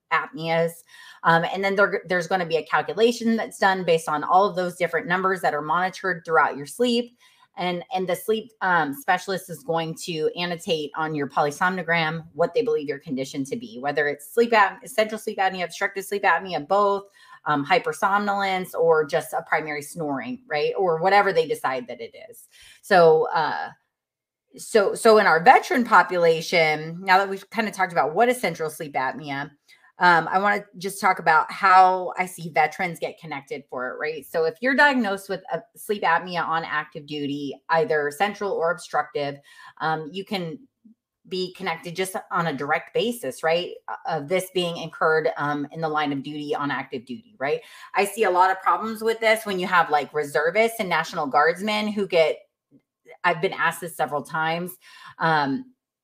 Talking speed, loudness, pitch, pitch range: 185 wpm, -23 LUFS, 185 Hz, 160-210 Hz